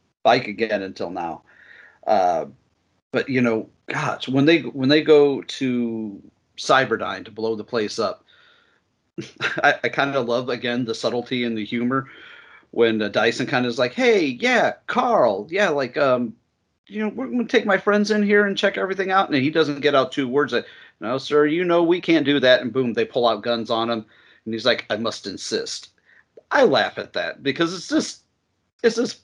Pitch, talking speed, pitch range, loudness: 140 Hz, 200 wpm, 120-190 Hz, -21 LUFS